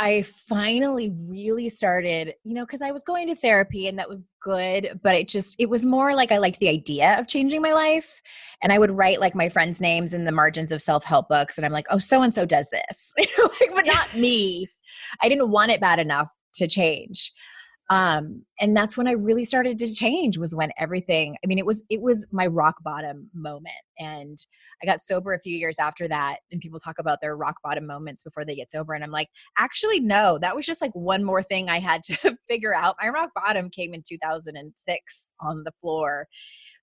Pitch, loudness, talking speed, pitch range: 190 Hz, -23 LUFS, 220 wpm, 160-230 Hz